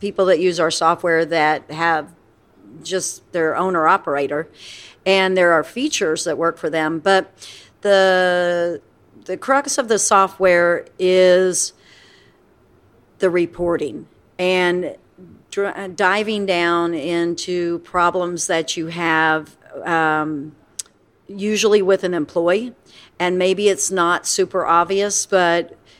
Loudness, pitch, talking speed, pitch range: -18 LUFS, 175 Hz, 115 wpm, 165-190 Hz